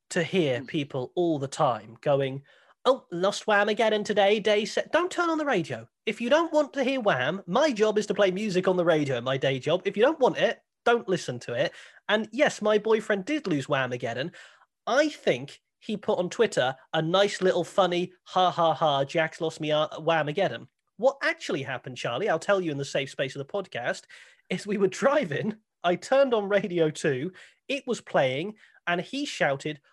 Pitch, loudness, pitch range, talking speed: 190 Hz, -26 LUFS, 160-220 Hz, 205 wpm